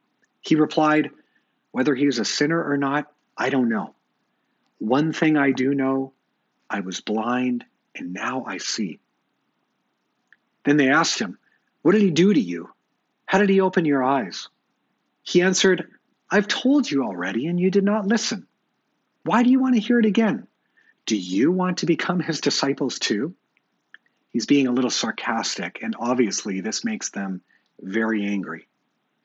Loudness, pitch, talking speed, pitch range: -22 LUFS, 155 Hz, 160 wpm, 135-205 Hz